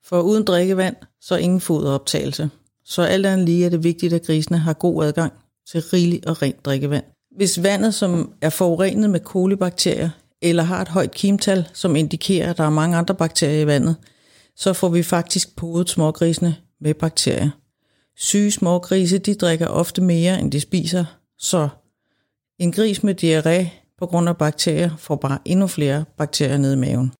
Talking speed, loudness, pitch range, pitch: 175 wpm, -19 LUFS, 155-185 Hz, 170 Hz